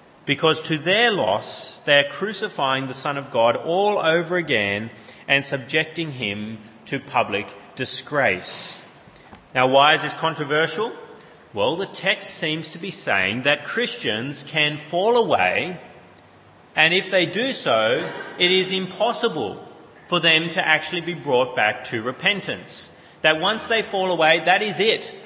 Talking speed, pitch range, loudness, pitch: 145 wpm, 140-190 Hz, -20 LUFS, 160 Hz